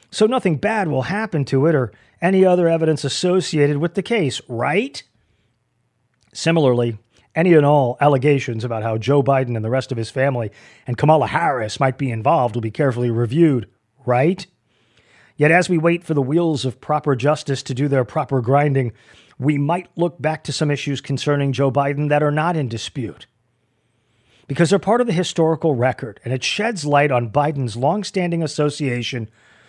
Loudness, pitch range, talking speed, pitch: -19 LUFS, 125-160 Hz, 175 wpm, 140 Hz